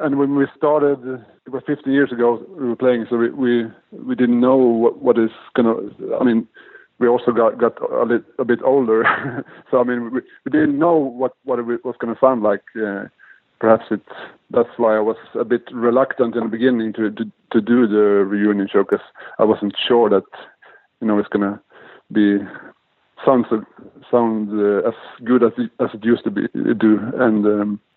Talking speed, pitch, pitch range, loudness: 200 wpm, 120 Hz, 110-130 Hz, -18 LUFS